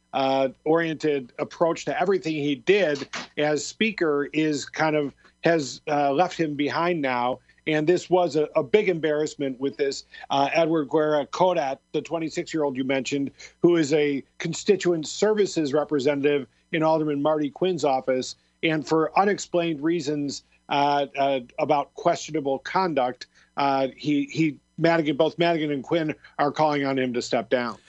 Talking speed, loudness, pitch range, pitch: 155 wpm, -24 LUFS, 140-165 Hz, 150 Hz